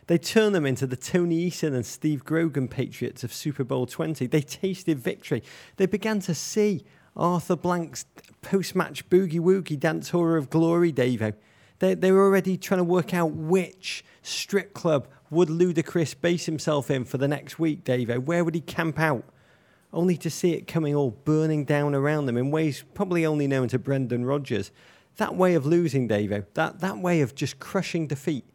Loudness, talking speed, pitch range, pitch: -25 LUFS, 185 wpm, 140-175 Hz, 160 Hz